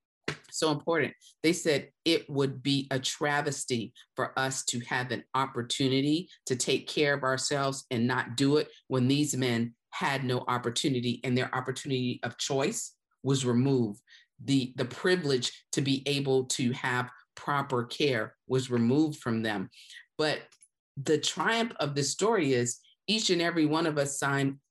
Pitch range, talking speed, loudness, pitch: 125-145 Hz, 160 wpm, -29 LUFS, 135 Hz